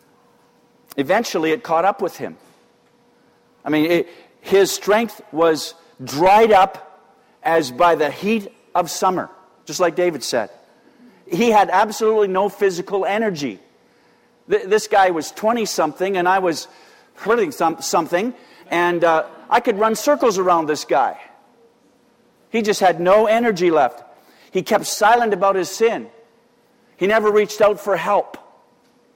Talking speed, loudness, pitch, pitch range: 140 wpm, -18 LUFS, 195 Hz, 175-225 Hz